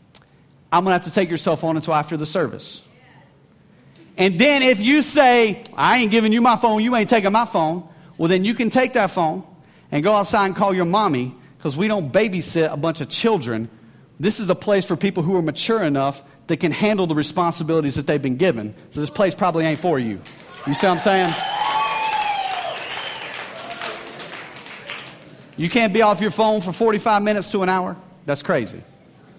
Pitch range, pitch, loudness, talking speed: 160-215 Hz, 185 Hz, -19 LUFS, 195 wpm